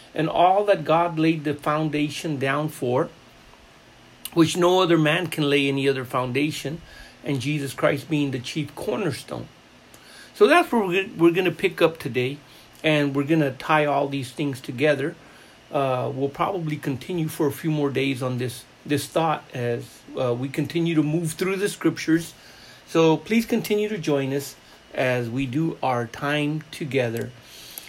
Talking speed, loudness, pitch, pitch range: 165 wpm, -23 LUFS, 150 Hz, 140-165 Hz